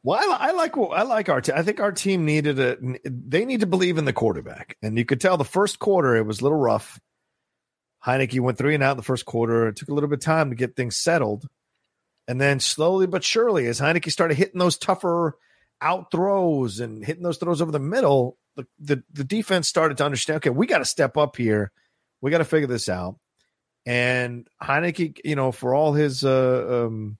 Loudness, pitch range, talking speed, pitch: -22 LUFS, 125-170 Hz, 225 wpm, 145 Hz